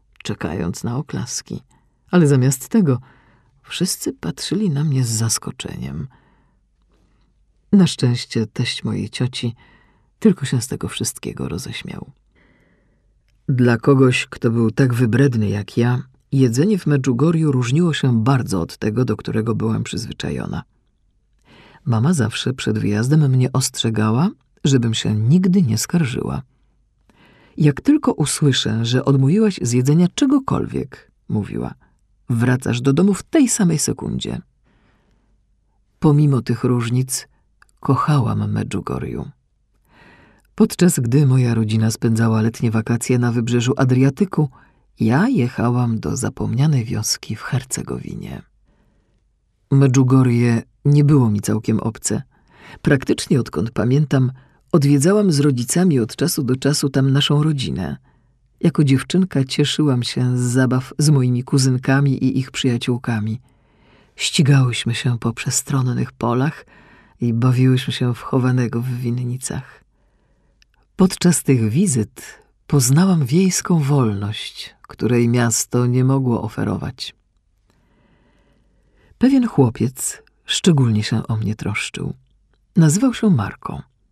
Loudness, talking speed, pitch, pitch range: -18 LUFS, 110 wpm, 130 Hz, 115-145 Hz